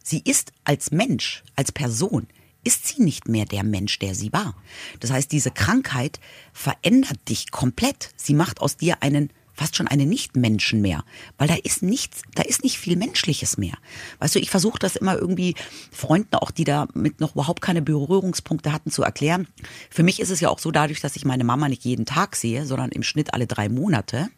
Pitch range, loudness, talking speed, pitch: 125-175 Hz, -22 LUFS, 200 wpm, 145 Hz